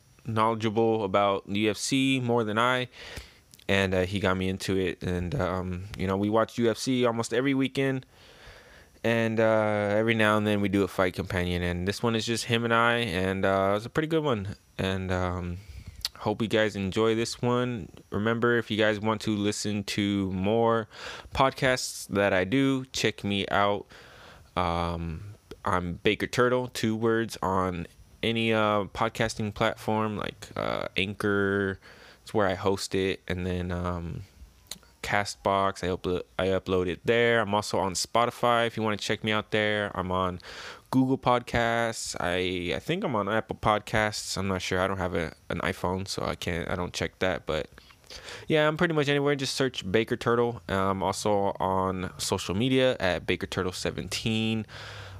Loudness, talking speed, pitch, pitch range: -27 LUFS, 175 wpm, 105 Hz, 95-115 Hz